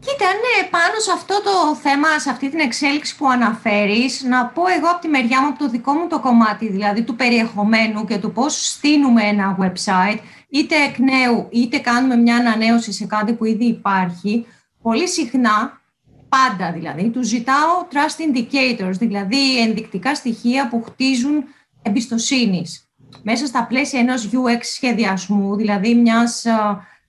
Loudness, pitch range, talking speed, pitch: -17 LUFS, 220-275 Hz, 155 wpm, 240 Hz